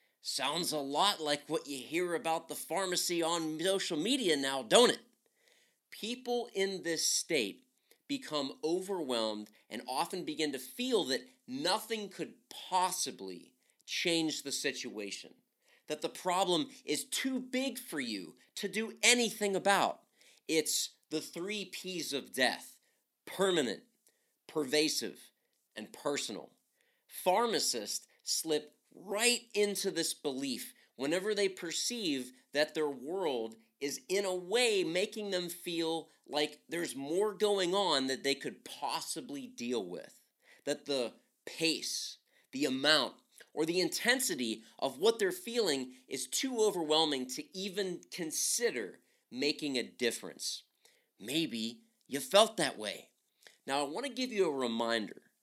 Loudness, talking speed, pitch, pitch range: -34 LUFS, 130 wpm, 175 Hz, 150-220 Hz